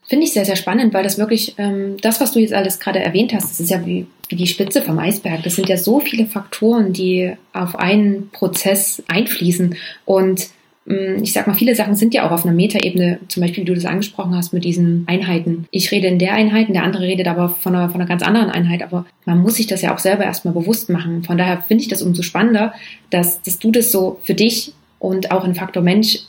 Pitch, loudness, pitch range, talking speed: 190 Hz, -16 LUFS, 180-210 Hz, 240 wpm